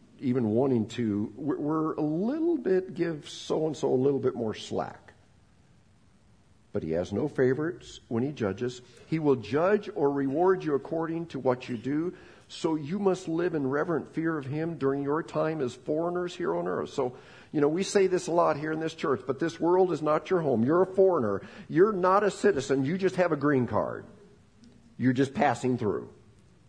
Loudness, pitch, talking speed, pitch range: -28 LUFS, 150 Hz, 200 wpm, 125-170 Hz